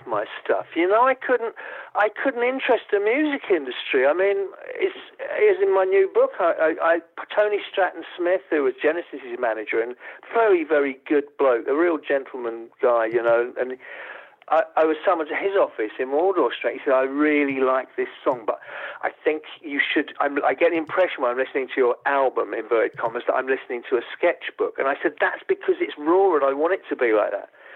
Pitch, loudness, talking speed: 255 Hz, -22 LUFS, 210 wpm